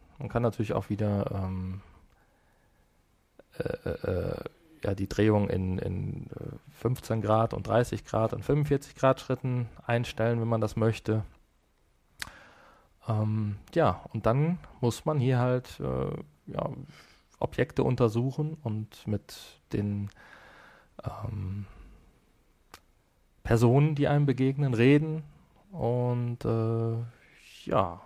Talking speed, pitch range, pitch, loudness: 110 wpm, 100-130 Hz, 115 Hz, -29 LUFS